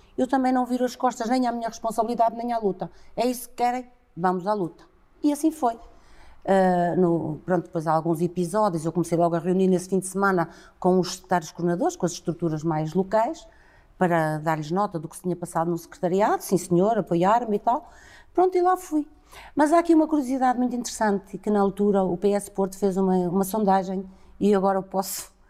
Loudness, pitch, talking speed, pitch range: -24 LUFS, 195 Hz, 205 wpm, 175-240 Hz